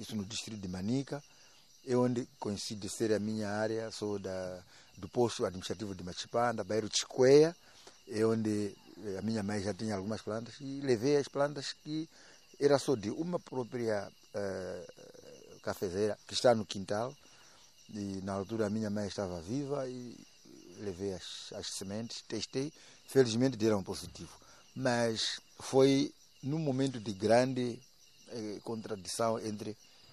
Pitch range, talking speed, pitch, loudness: 105-130 Hz, 150 wpm, 110 Hz, -34 LUFS